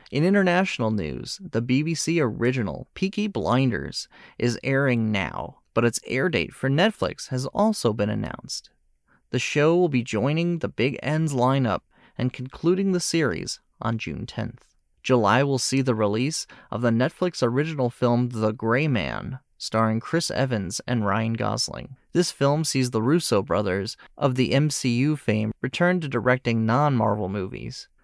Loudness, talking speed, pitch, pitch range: -24 LUFS, 150 wpm, 125 Hz, 115-150 Hz